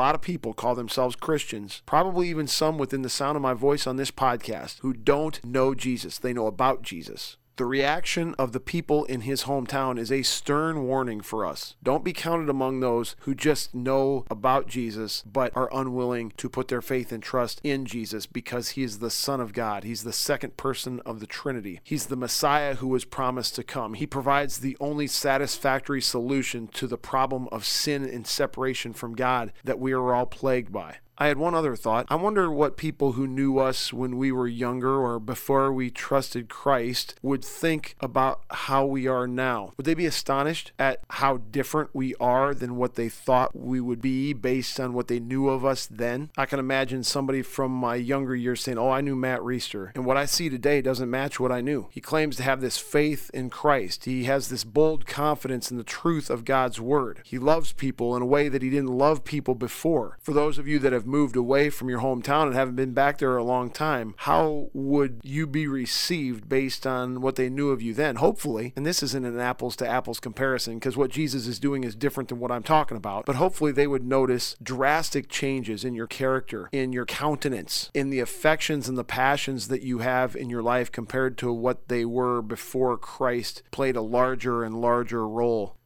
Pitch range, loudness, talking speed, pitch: 125-140 Hz, -26 LUFS, 210 wpm, 130 Hz